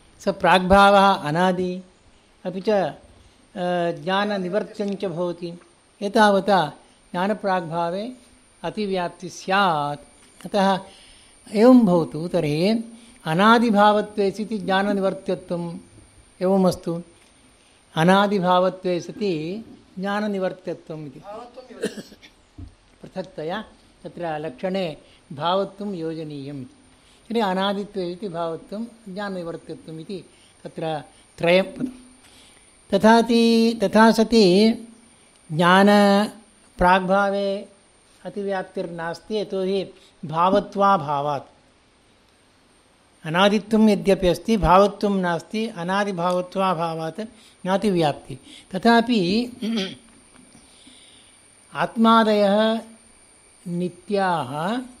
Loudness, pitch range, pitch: -21 LUFS, 175-210 Hz, 195 Hz